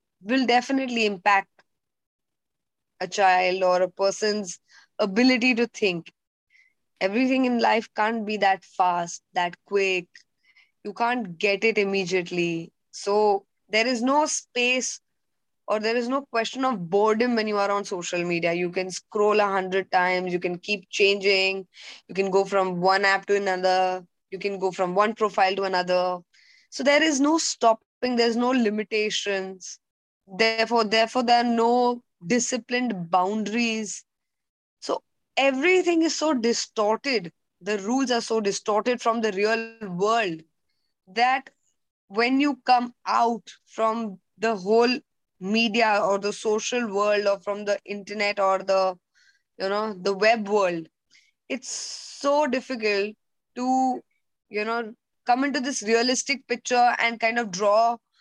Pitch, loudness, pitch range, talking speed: 215 Hz, -24 LUFS, 195-240 Hz, 140 wpm